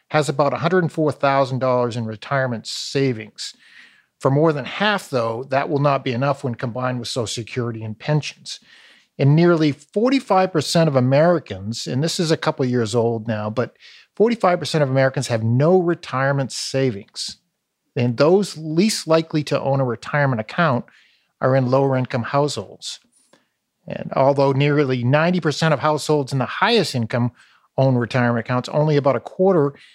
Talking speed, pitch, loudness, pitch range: 150 wpm, 140 Hz, -20 LUFS, 125-155 Hz